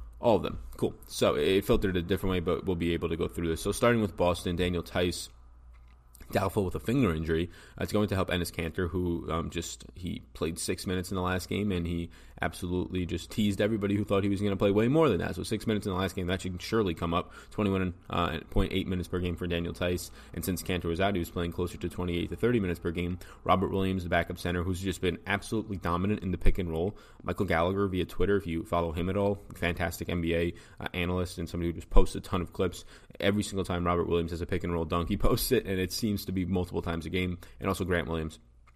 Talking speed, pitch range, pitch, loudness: 255 wpm, 85-100 Hz, 90 Hz, -31 LUFS